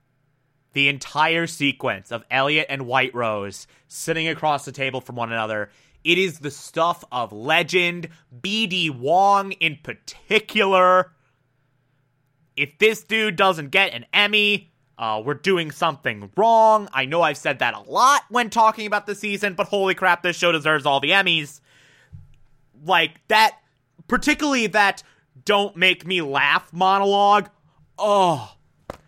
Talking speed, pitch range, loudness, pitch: 140 wpm, 135-195 Hz, -20 LUFS, 165 Hz